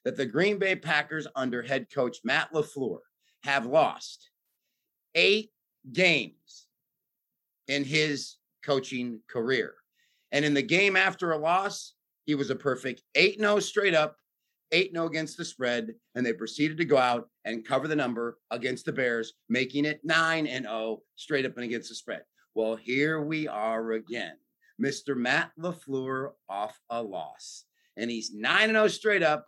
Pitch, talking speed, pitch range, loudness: 150 Hz, 165 wpm, 125-180 Hz, -28 LUFS